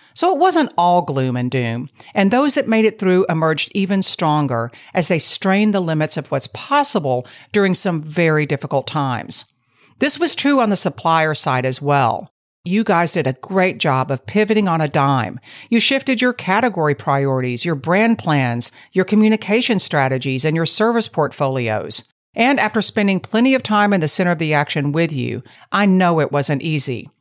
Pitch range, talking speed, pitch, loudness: 140-210 Hz, 185 wpm, 165 Hz, -17 LUFS